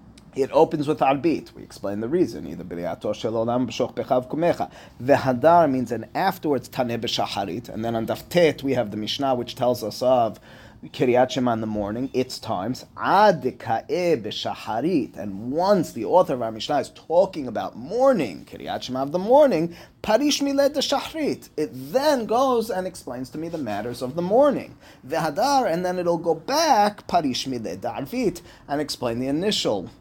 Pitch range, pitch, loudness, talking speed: 120-195 Hz, 140 Hz, -23 LUFS, 165 wpm